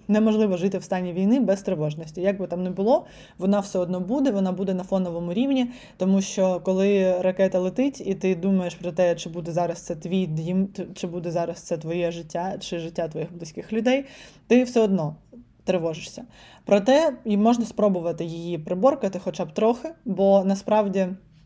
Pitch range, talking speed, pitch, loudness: 175-210 Hz, 175 wpm, 190 Hz, -24 LUFS